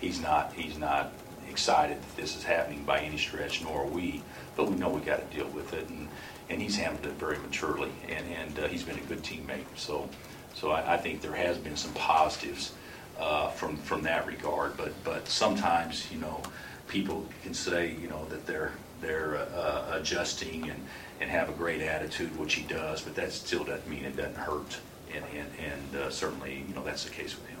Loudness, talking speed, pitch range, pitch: -33 LUFS, 210 wpm, 70-85 Hz, 75 Hz